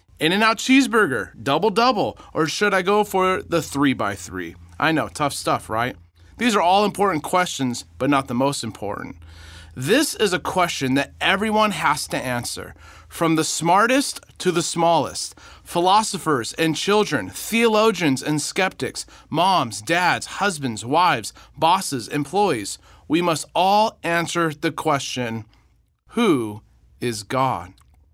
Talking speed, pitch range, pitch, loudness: 140 wpm, 125-195 Hz, 155 Hz, -21 LUFS